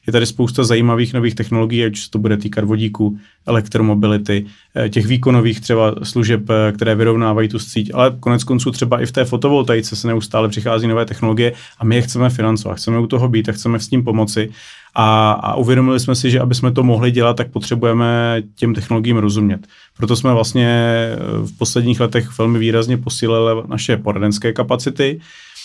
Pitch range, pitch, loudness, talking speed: 110-120 Hz, 115 Hz, -16 LUFS, 180 wpm